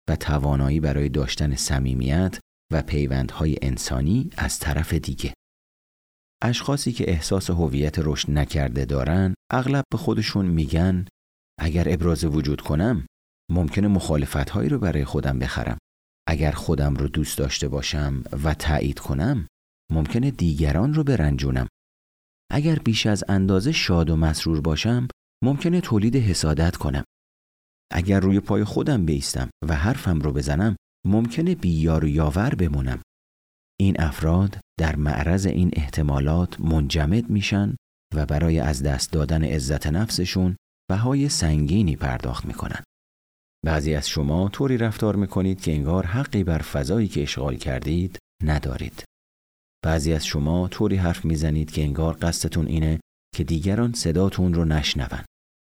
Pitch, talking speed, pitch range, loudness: 80 Hz, 130 wpm, 70-95 Hz, -23 LUFS